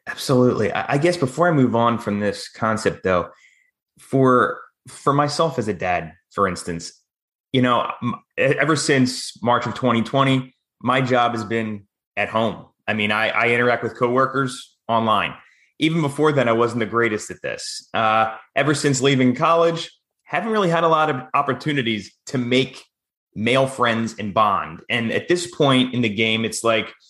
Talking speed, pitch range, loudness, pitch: 170 wpm, 115-140 Hz, -20 LUFS, 125 Hz